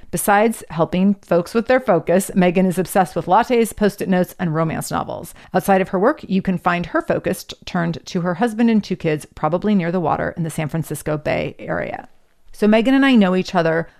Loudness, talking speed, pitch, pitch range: -19 LUFS, 215 wpm, 185 Hz, 170-205 Hz